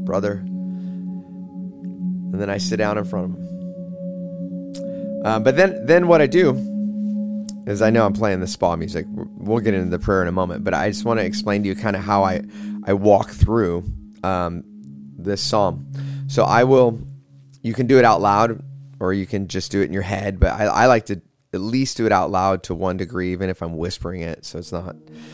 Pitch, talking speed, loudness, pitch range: 100 Hz, 215 wpm, -20 LUFS, 90-125 Hz